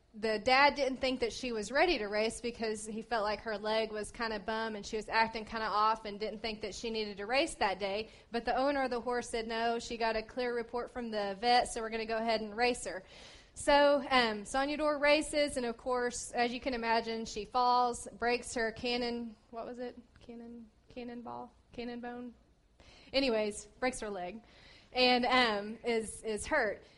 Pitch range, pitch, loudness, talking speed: 220-250 Hz, 235 Hz, -33 LUFS, 215 wpm